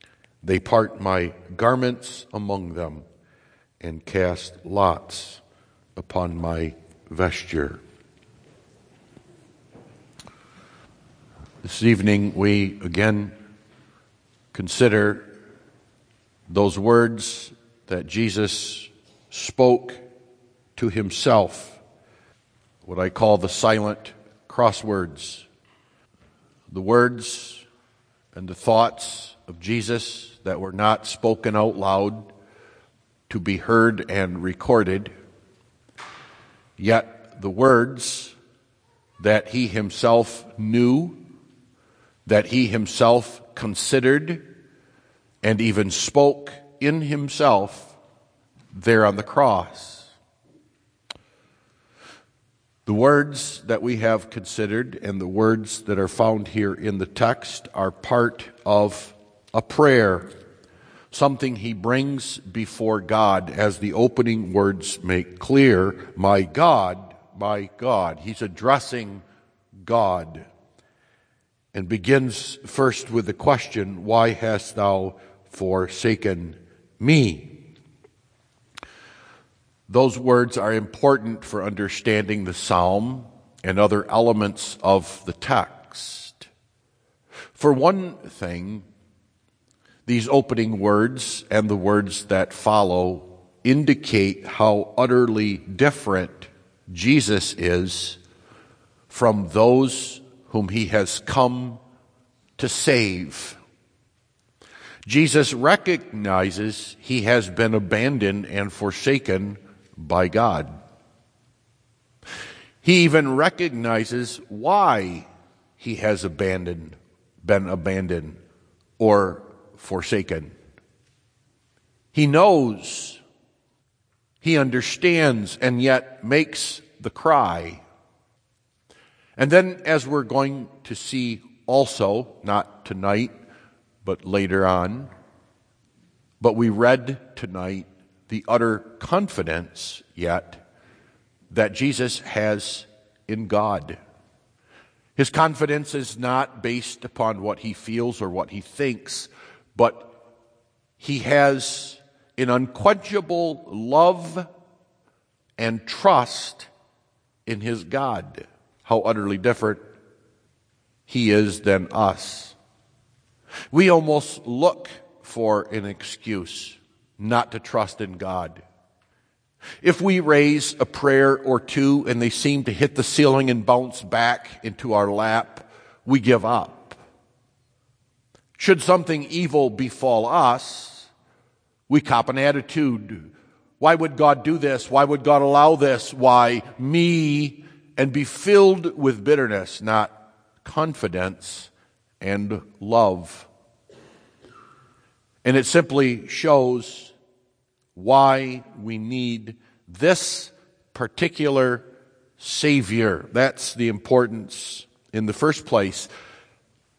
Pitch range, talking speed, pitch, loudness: 100-130 Hz, 95 wpm, 115 Hz, -21 LUFS